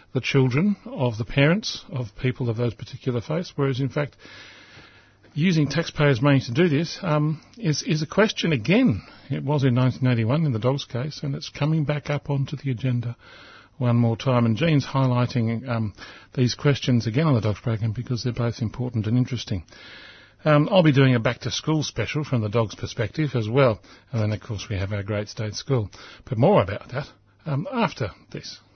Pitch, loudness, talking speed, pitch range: 130 Hz, -23 LUFS, 190 wpm, 115-145 Hz